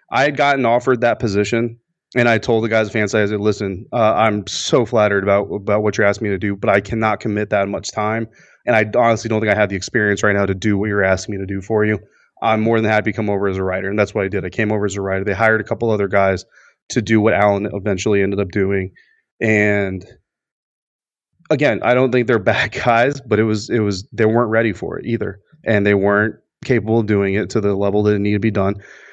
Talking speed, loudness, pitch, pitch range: 260 wpm, -17 LUFS, 105 Hz, 100-115 Hz